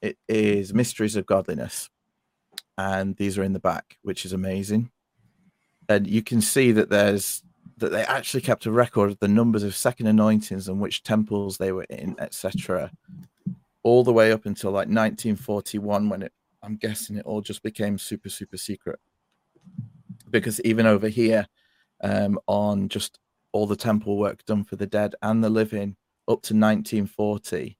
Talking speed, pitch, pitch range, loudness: 170 wpm, 105 Hz, 100-110 Hz, -24 LUFS